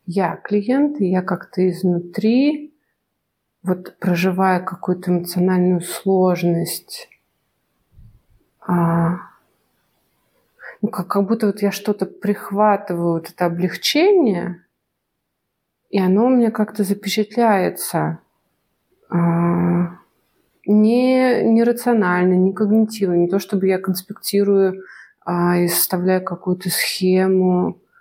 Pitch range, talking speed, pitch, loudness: 175-210 Hz, 95 wpm, 185 Hz, -18 LUFS